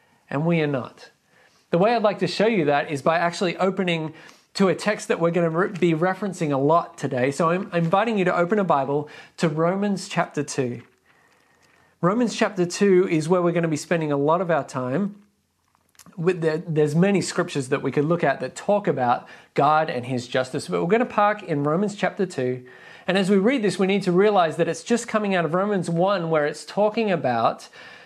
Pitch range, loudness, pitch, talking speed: 150-195 Hz, -22 LUFS, 170 Hz, 220 wpm